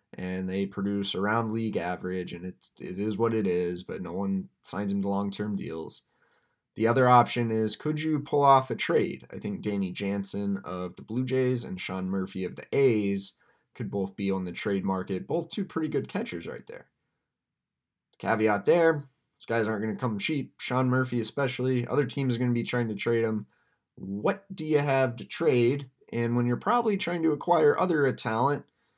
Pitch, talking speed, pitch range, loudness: 115 Hz, 195 wpm, 100-130 Hz, -28 LUFS